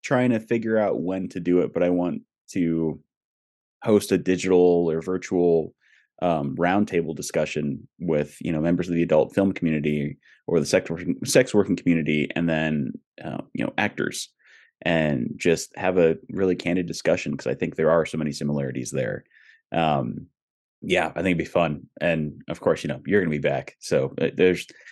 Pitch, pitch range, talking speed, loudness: 85 Hz, 75-90 Hz, 185 wpm, -24 LUFS